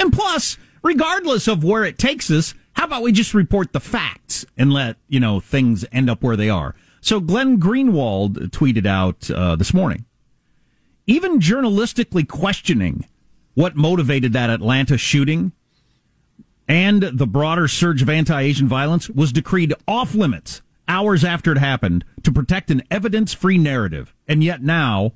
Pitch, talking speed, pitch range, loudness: 155 Hz, 155 wpm, 125-195 Hz, -18 LUFS